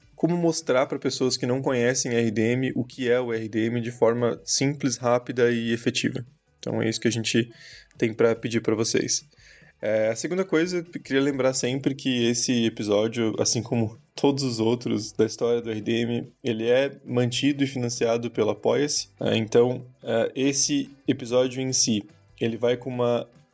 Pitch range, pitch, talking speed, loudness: 115-135 Hz, 120 Hz, 175 wpm, -25 LUFS